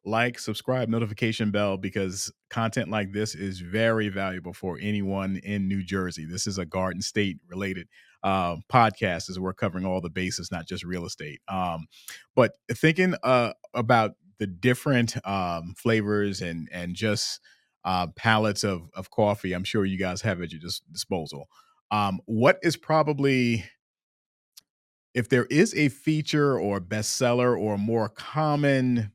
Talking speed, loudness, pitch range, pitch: 150 wpm, -26 LUFS, 95-115 Hz, 105 Hz